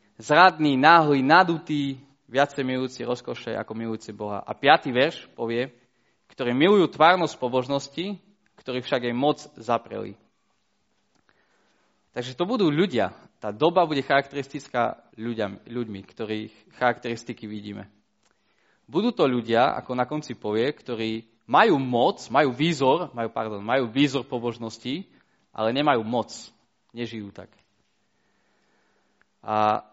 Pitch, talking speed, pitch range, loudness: 125 Hz, 115 wpm, 110-140 Hz, -24 LUFS